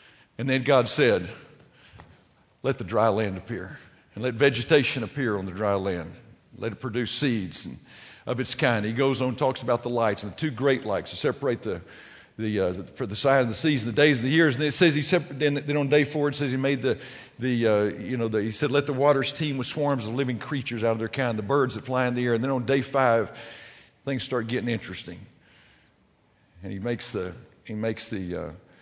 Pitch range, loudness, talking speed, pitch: 110-140 Hz, -25 LUFS, 235 wpm, 125 Hz